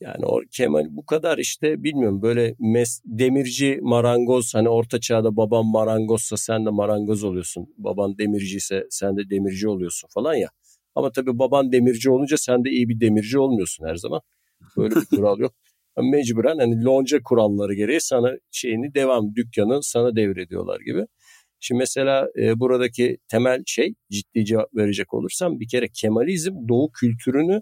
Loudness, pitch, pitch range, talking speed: -21 LUFS, 115 Hz, 105-130 Hz, 160 wpm